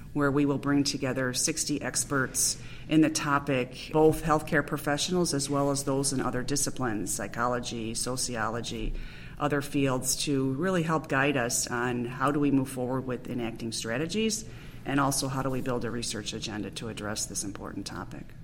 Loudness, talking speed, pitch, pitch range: -29 LUFS, 170 wpm, 130 Hz, 120-145 Hz